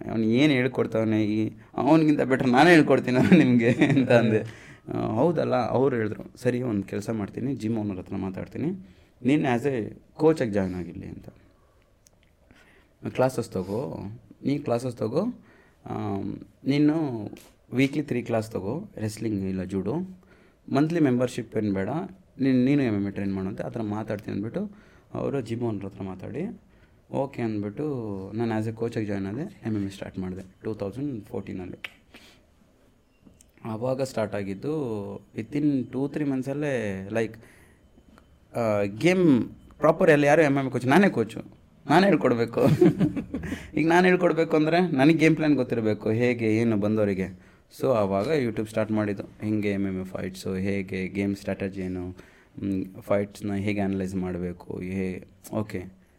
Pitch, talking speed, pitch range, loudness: 110 Hz, 135 wpm, 100-130 Hz, -25 LUFS